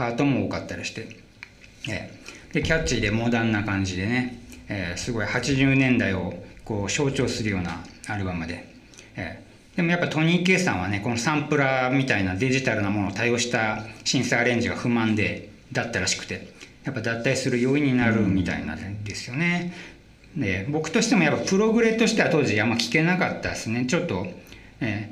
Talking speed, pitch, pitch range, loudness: 375 characters per minute, 120 Hz, 100-135 Hz, -24 LUFS